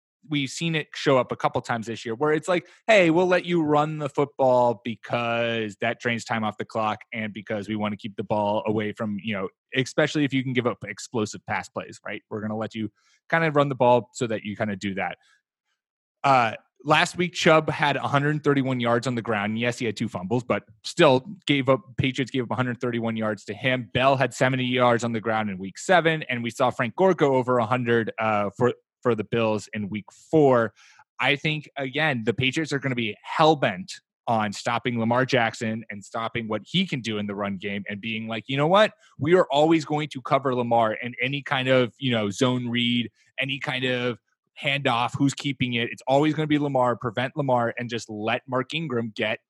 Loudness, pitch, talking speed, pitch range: -24 LUFS, 125 Hz, 225 wpm, 115-140 Hz